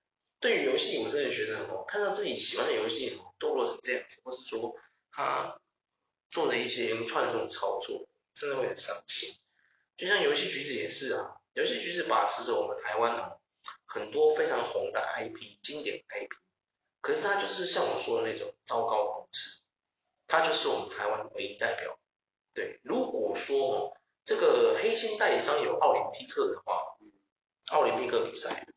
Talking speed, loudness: 265 characters per minute, -30 LUFS